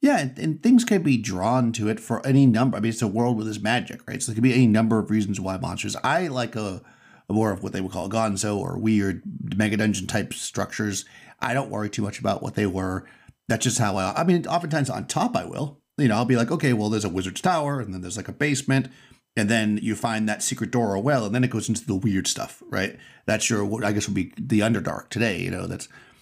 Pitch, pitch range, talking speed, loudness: 110 Hz, 105-130 Hz, 265 wpm, -24 LUFS